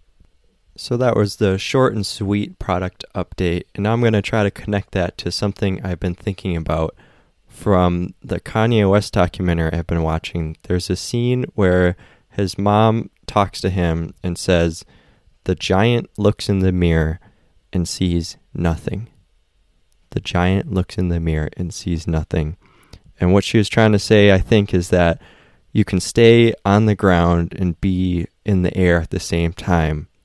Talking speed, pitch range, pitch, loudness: 175 wpm, 85-105 Hz, 95 Hz, -18 LUFS